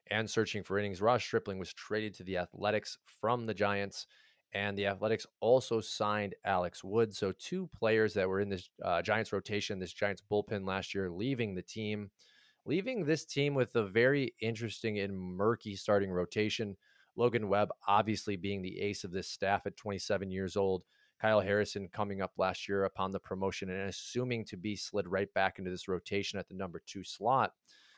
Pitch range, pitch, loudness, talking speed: 95-110 Hz, 100 Hz, -34 LUFS, 185 wpm